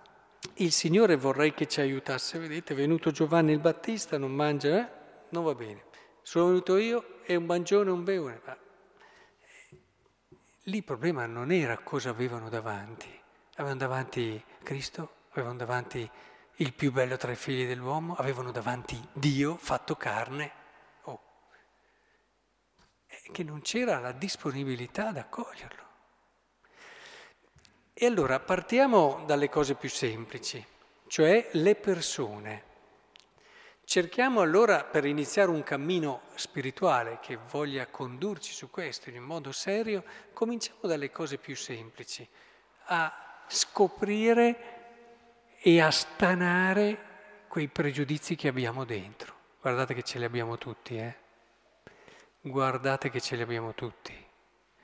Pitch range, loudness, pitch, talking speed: 130-190 Hz, -30 LUFS, 150 Hz, 125 wpm